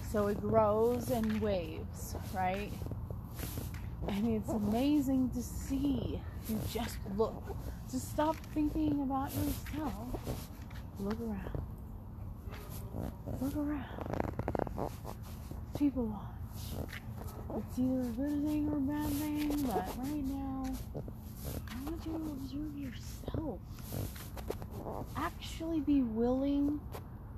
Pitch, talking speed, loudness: 220 Hz, 100 wpm, -37 LUFS